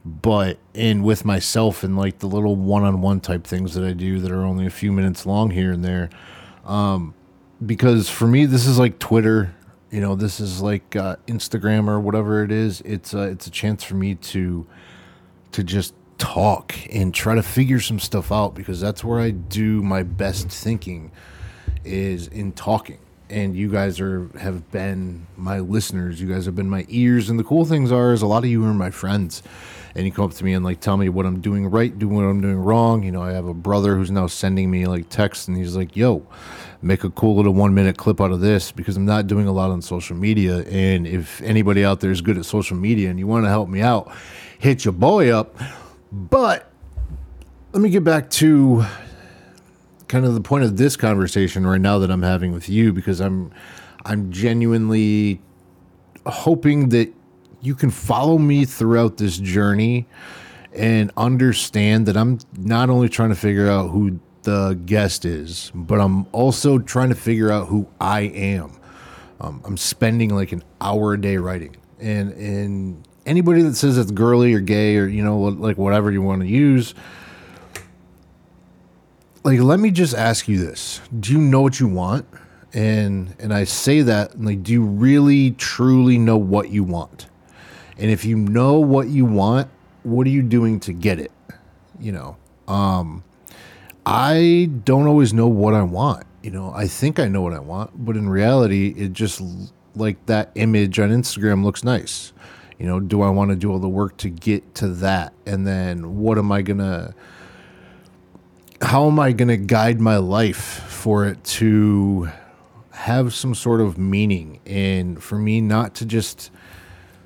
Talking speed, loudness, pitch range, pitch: 190 wpm, -19 LUFS, 95-115 Hz, 100 Hz